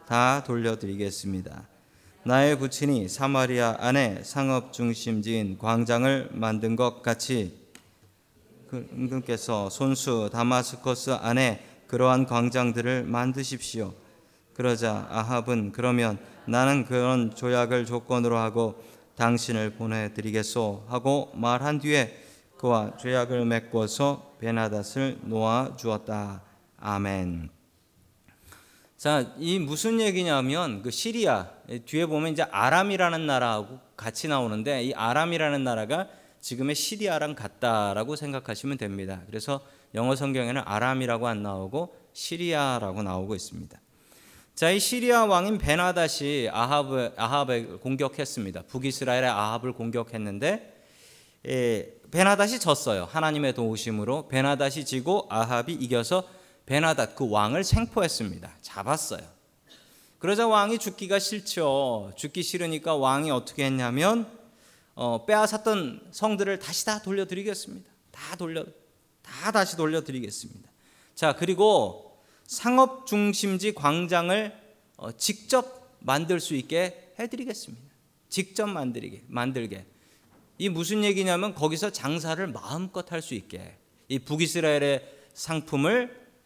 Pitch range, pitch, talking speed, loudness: 115-165 Hz, 130 Hz, 285 characters per minute, -27 LUFS